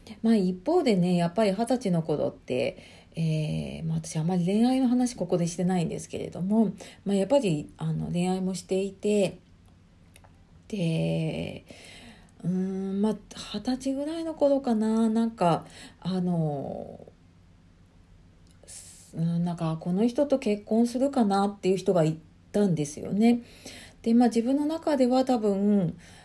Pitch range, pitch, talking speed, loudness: 155-225 Hz, 185 Hz, 270 characters per minute, -27 LUFS